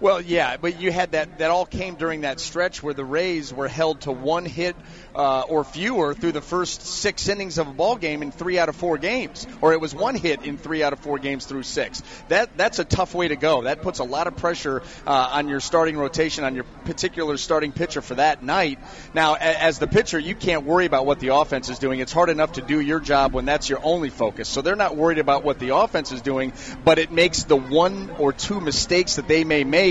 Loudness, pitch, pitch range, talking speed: -22 LUFS, 155 Hz, 140-170 Hz, 245 wpm